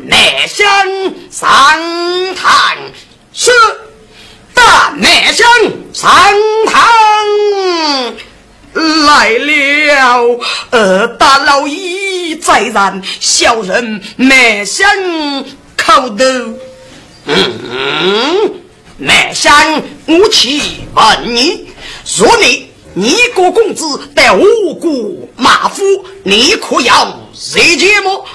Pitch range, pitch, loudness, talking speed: 275-400 Hz, 345 Hz, -8 LUFS, 105 characters per minute